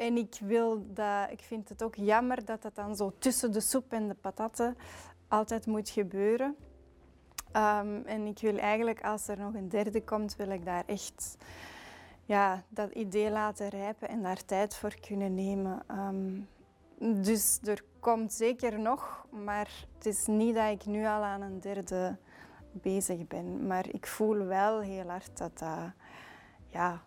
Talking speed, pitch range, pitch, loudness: 170 wpm, 195-225 Hz, 210 Hz, -33 LUFS